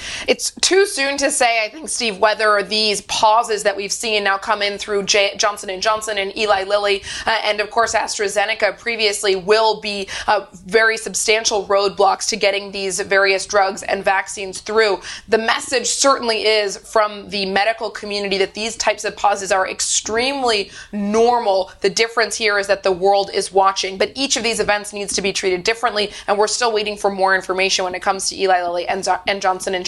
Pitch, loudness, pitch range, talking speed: 205 Hz, -17 LUFS, 195-220 Hz, 195 wpm